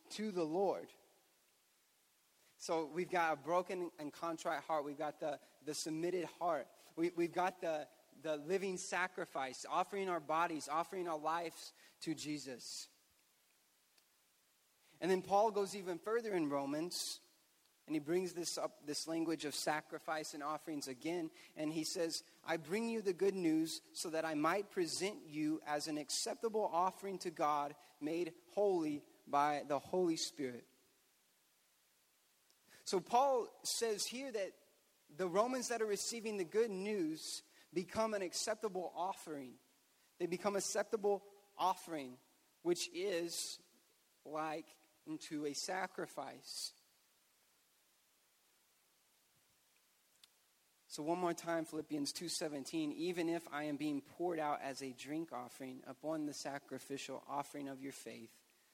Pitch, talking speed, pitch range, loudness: 170 Hz, 135 wpm, 150-195 Hz, -41 LUFS